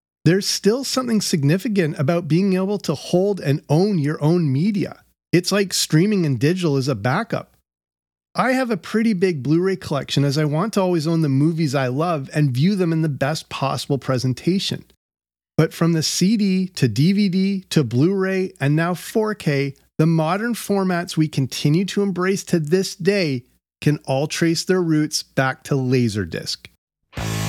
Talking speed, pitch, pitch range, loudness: 170 wpm, 165 Hz, 140-190 Hz, -20 LUFS